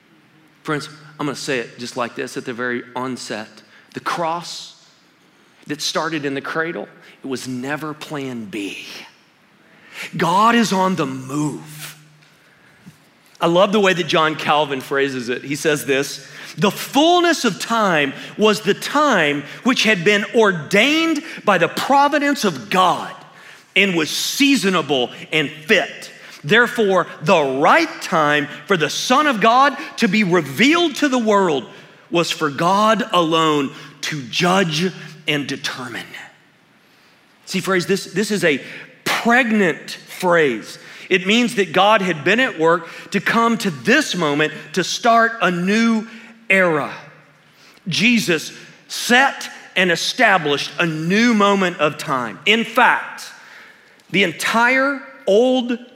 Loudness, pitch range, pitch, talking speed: -17 LUFS, 150-225 Hz, 180 Hz, 135 wpm